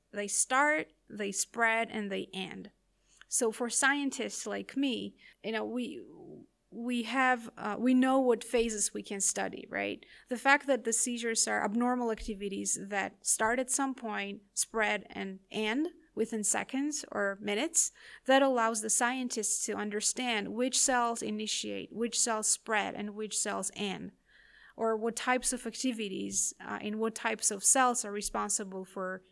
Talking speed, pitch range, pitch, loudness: 155 wpm, 210-250 Hz, 225 Hz, -31 LUFS